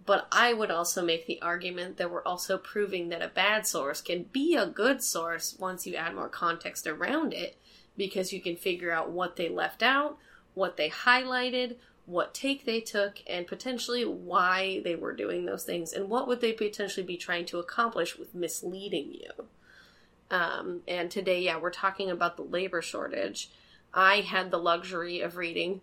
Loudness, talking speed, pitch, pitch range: -30 LUFS, 185 wpm, 190 Hz, 175-230 Hz